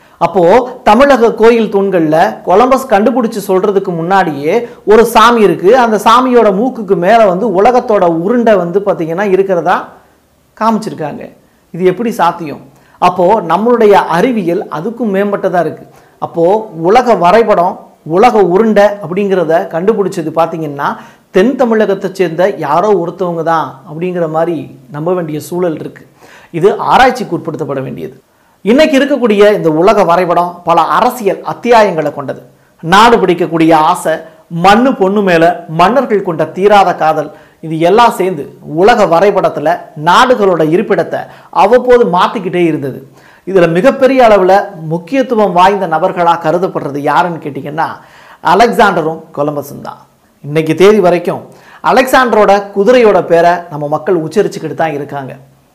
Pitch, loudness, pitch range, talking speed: 185 Hz, -10 LUFS, 165-220 Hz, 115 wpm